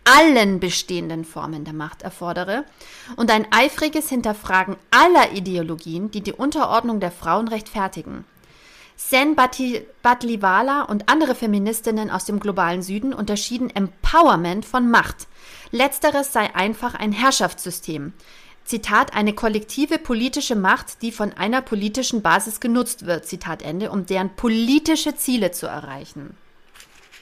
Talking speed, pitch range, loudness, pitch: 125 wpm, 185-255 Hz, -20 LUFS, 215 Hz